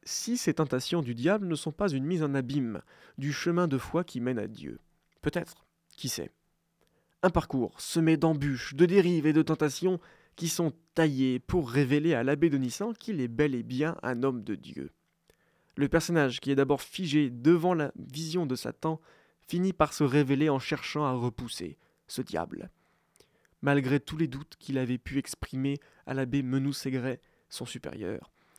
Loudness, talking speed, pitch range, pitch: -30 LUFS, 175 wpm, 130-165 Hz, 145 Hz